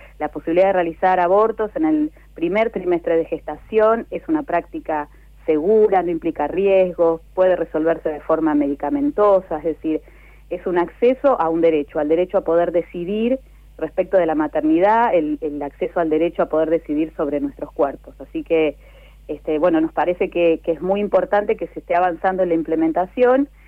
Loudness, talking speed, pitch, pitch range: -19 LUFS, 175 wpm, 170 Hz, 160-195 Hz